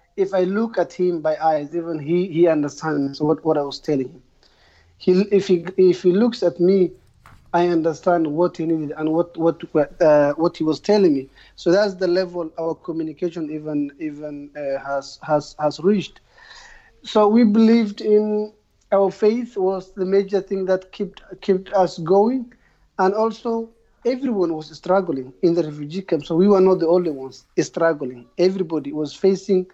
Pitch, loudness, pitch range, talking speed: 175 Hz, -20 LUFS, 155-195 Hz, 175 wpm